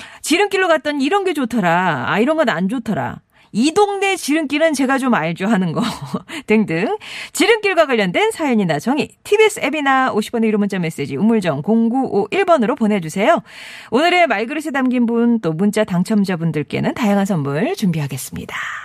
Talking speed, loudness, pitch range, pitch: 345 characters per minute, -17 LUFS, 200-310 Hz, 225 Hz